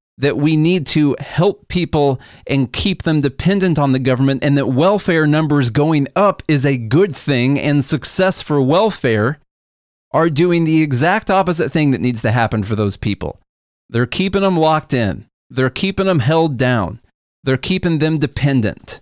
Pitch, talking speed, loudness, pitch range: 145 Hz, 170 wpm, -16 LUFS, 125-165 Hz